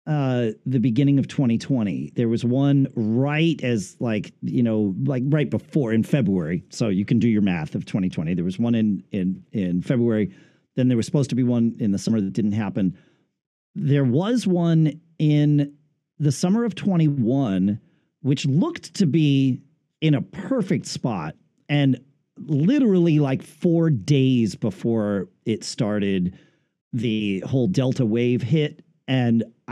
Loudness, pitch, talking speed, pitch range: -22 LUFS, 130 Hz, 155 wpm, 115-155 Hz